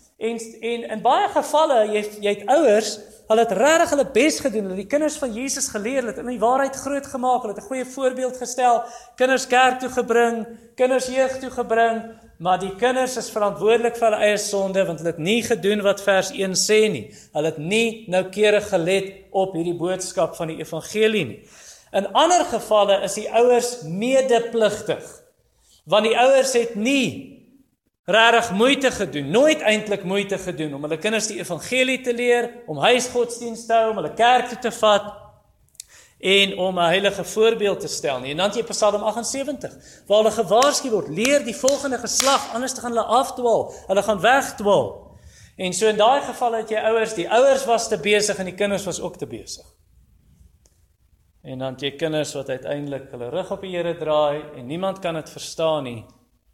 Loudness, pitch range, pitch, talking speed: -20 LUFS, 190-245 Hz, 220 Hz, 185 wpm